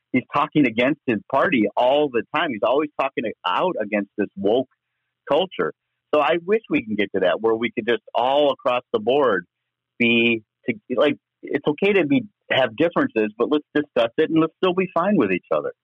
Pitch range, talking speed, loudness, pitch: 115-175 Hz, 200 wpm, -21 LUFS, 150 Hz